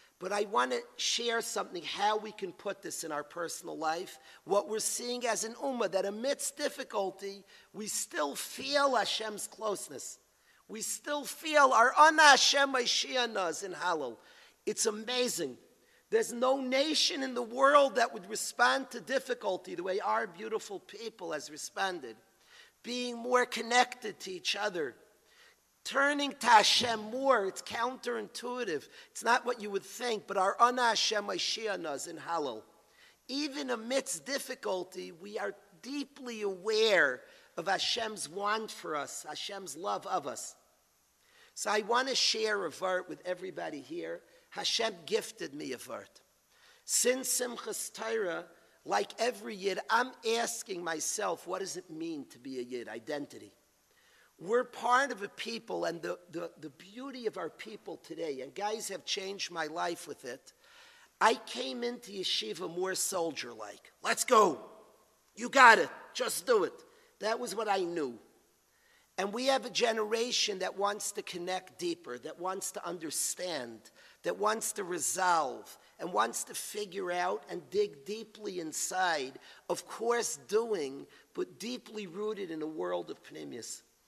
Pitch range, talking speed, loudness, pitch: 200-280 Hz, 150 wpm, -32 LUFS, 235 Hz